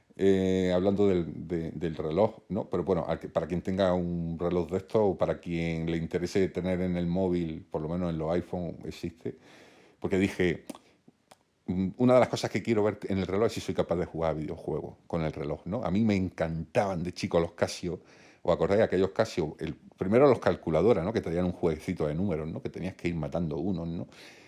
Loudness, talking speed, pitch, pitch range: -29 LUFS, 215 wpm, 90 Hz, 85-95 Hz